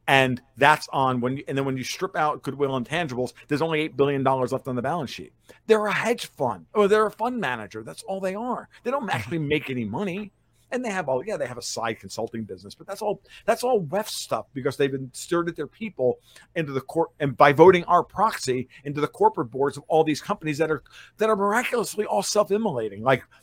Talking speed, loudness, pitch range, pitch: 235 wpm, -24 LUFS, 130-200 Hz, 150 Hz